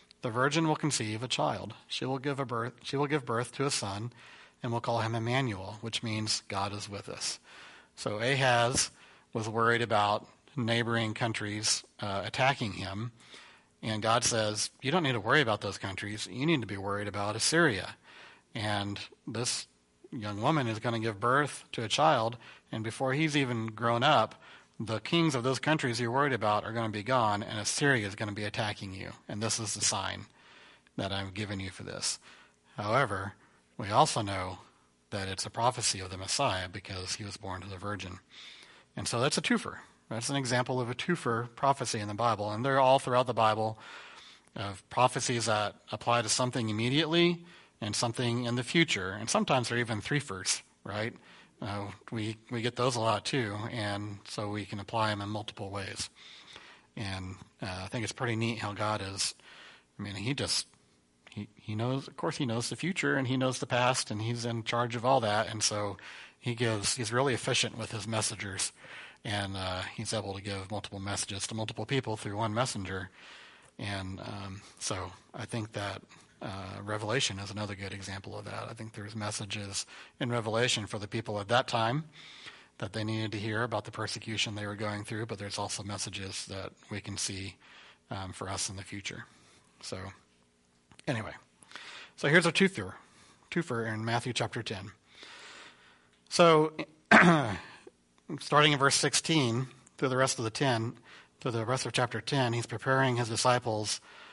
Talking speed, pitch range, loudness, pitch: 185 wpm, 100-125 Hz, -31 LUFS, 110 Hz